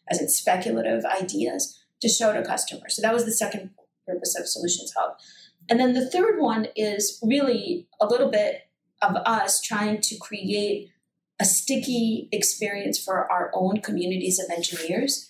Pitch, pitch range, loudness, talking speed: 215 Hz, 200-245 Hz, -24 LUFS, 160 wpm